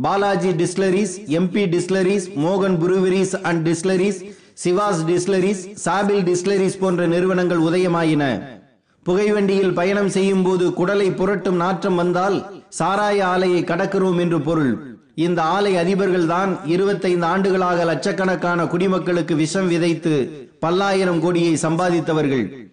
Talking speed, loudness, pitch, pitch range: 110 wpm, -19 LUFS, 185 Hz, 170-195 Hz